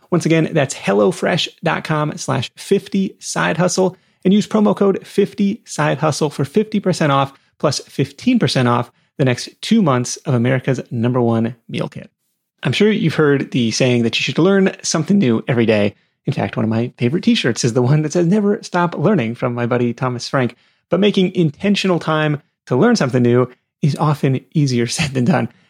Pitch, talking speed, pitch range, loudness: 150 Hz, 185 wpm, 125-185 Hz, -17 LUFS